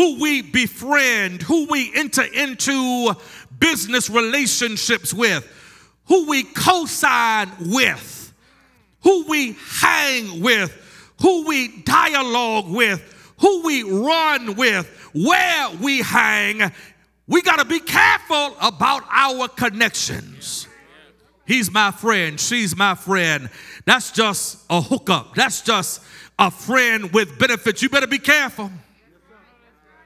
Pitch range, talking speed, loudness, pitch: 215-285 Hz, 115 wpm, -17 LUFS, 250 Hz